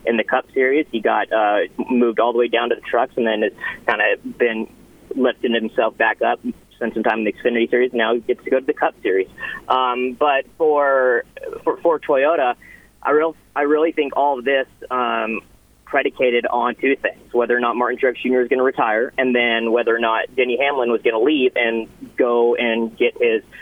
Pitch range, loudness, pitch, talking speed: 120-145 Hz, -19 LUFS, 125 Hz, 220 wpm